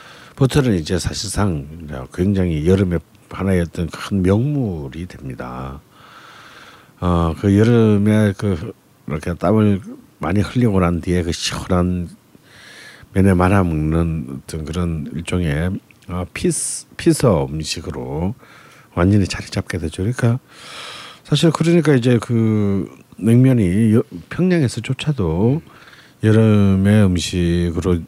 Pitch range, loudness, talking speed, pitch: 85-115 Hz, -18 LUFS, 230 characters per minute, 95 Hz